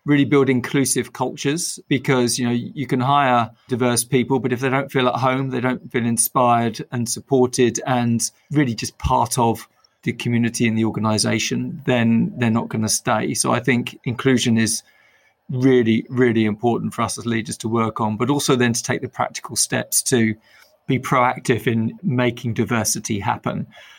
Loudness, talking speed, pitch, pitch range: -20 LUFS, 180 wpm, 120 Hz, 115-130 Hz